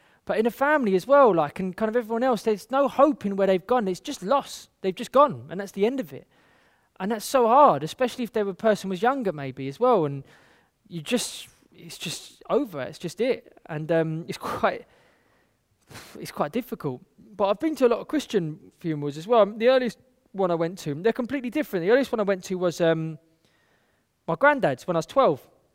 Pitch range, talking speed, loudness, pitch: 165-250 Hz, 220 wpm, -24 LUFS, 205 Hz